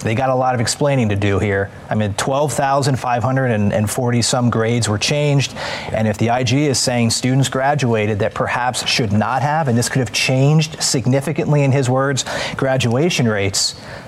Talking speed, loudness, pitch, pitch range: 170 wpm, -17 LUFS, 130 Hz, 115-140 Hz